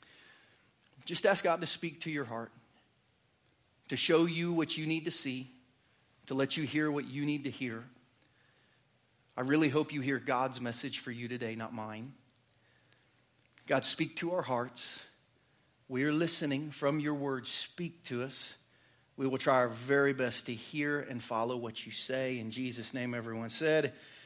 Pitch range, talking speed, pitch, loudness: 120-150 Hz, 170 wpm, 130 Hz, -34 LUFS